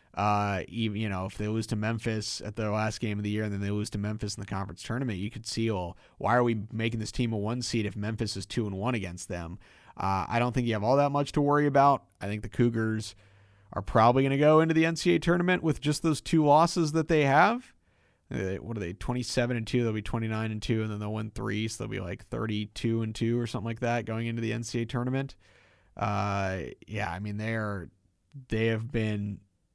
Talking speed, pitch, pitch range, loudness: 245 wpm, 110 Hz, 105-125 Hz, -29 LUFS